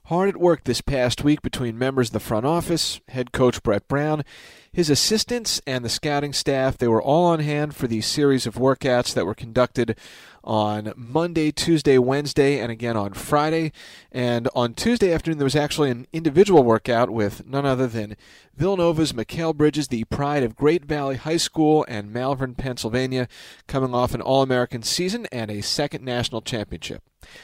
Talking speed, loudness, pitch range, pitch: 175 wpm, -22 LUFS, 120-150 Hz, 130 Hz